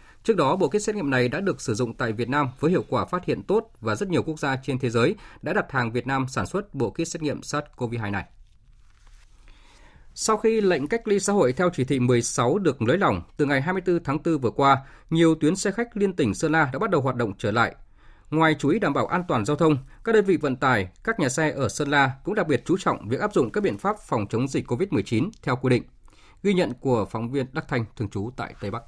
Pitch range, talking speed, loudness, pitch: 120-160 Hz, 265 wpm, -24 LUFS, 135 Hz